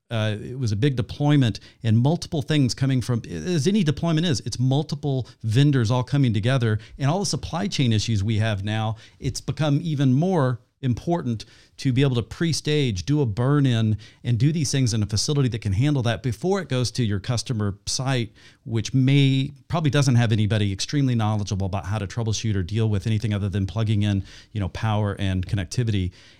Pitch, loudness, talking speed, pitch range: 120 Hz, -23 LUFS, 195 wpm, 110-140 Hz